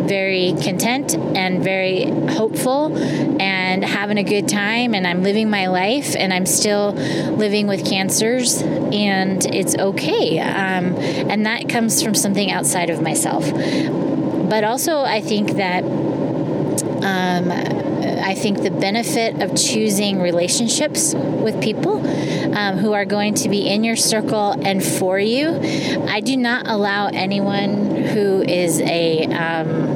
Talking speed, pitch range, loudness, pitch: 140 wpm, 185-220 Hz, -18 LUFS, 200 Hz